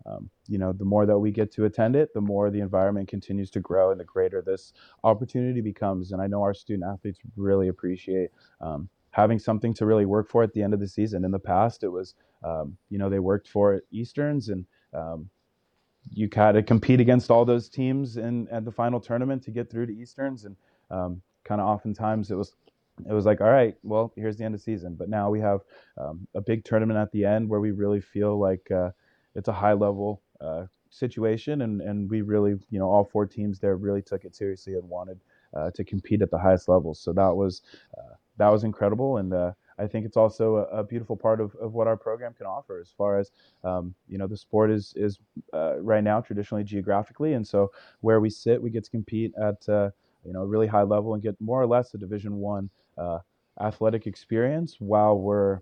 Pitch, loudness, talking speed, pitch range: 105 Hz, -26 LUFS, 225 wpm, 100-110 Hz